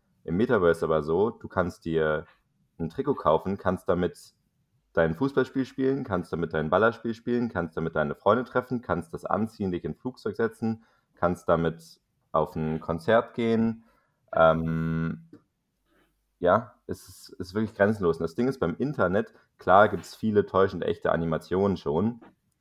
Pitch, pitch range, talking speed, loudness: 95 Hz, 80-115 Hz, 155 wpm, -27 LUFS